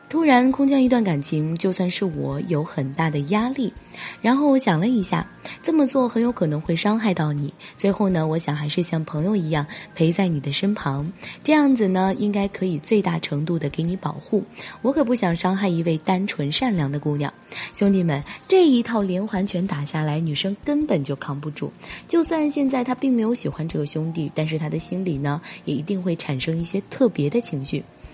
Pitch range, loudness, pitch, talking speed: 155-220 Hz, -22 LUFS, 185 Hz, 300 characters per minute